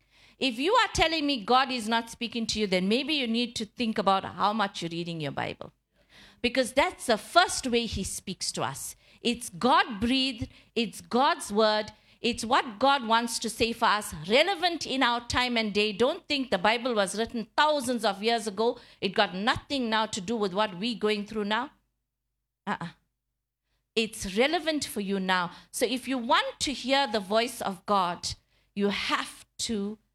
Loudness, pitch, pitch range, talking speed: -27 LUFS, 225 Hz, 200-255 Hz, 185 wpm